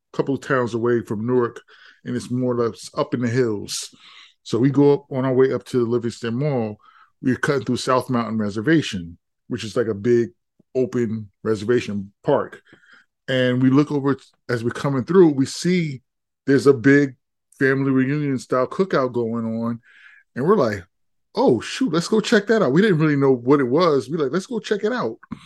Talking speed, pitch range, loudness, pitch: 200 wpm, 120-145 Hz, -21 LUFS, 130 Hz